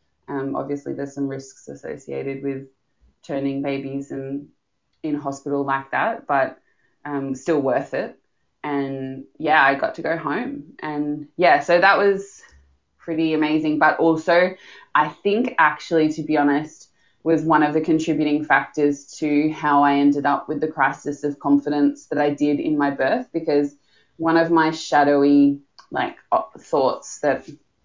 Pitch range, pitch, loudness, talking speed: 140-155 Hz, 145 Hz, -21 LUFS, 155 wpm